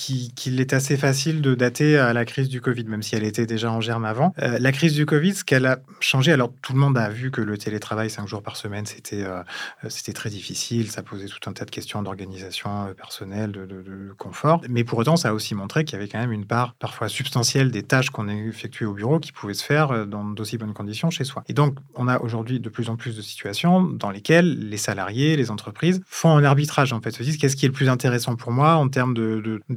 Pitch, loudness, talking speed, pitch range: 120 Hz, -22 LUFS, 260 wpm, 110-140 Hz